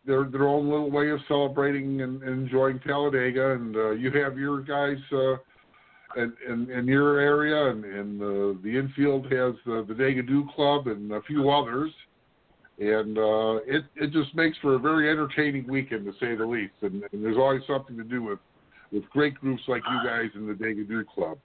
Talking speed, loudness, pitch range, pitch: 195 wpm, -26 LUFS, 115-145 Hz, 135 Hz